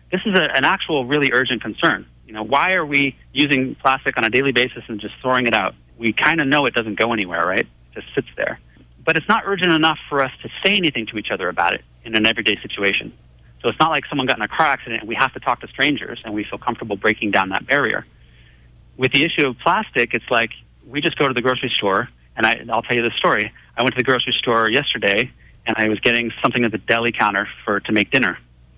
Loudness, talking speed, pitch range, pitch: -18 LUFS, 255 wpm, 105-135 Hz, 120 Hz